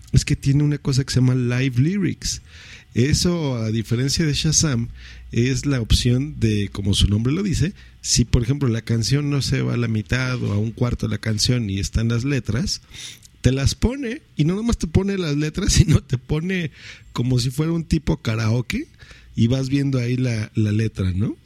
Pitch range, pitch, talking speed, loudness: 110-145 Hz, 125 Hz, 205 wpm, -21 LUFS